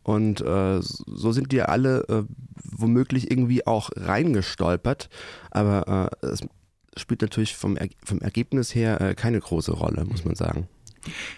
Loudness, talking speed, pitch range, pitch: -25 LUFS, 155 wpm, 95-125 Hz, 110 Hz